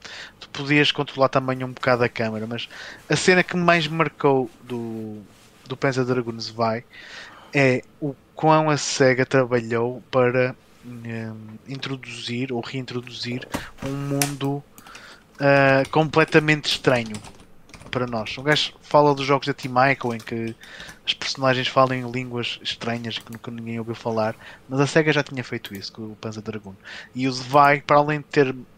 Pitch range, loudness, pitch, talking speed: 115-140 Hz, -22 LUFS, 130 Hz, 160 wpm